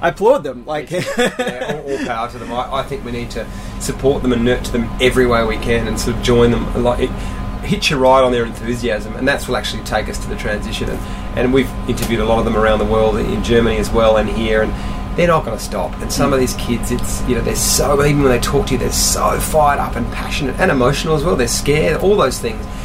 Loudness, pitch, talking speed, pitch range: -16 LUFS, 120 Hz, 260 wpm, 110-130 Hz